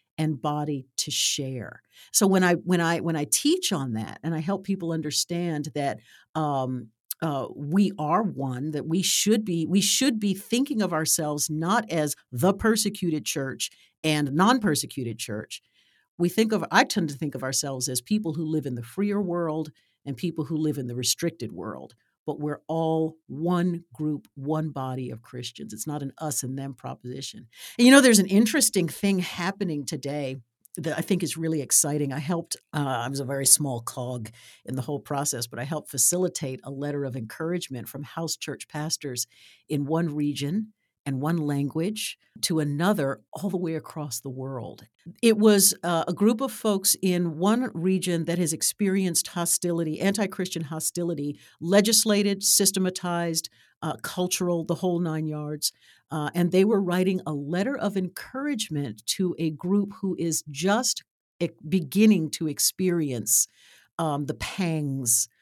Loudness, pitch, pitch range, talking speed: -25 LUFS, 160 Hz, 145-185 Hz, 170 wpm